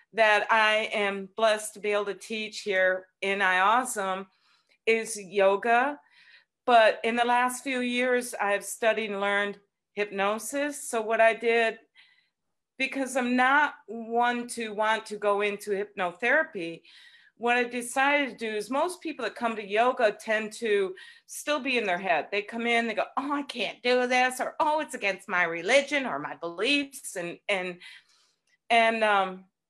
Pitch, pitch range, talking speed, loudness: 225 Hz, 200-255 Hz, 165 wpm, -26 LUFS